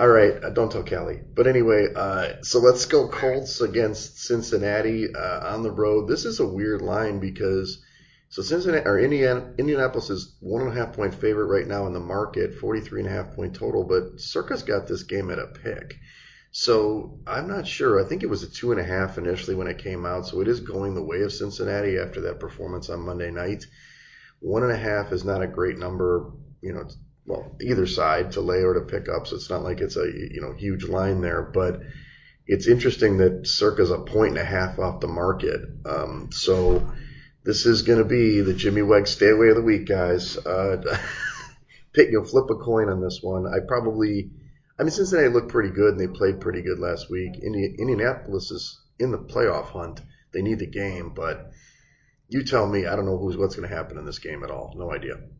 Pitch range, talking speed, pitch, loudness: 95-120 Hz, 220 wpm, 105 Hz, -24 LUFS